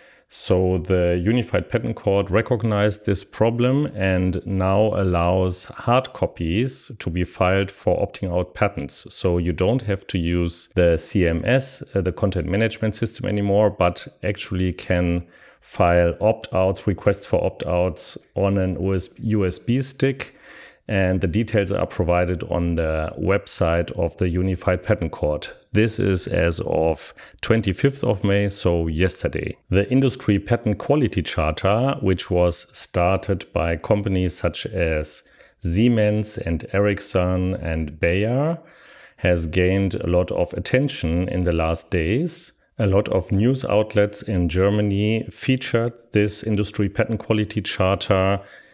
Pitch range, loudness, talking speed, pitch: 90-110 Hz, -22 LUFS, 135 wpm, 95 Hz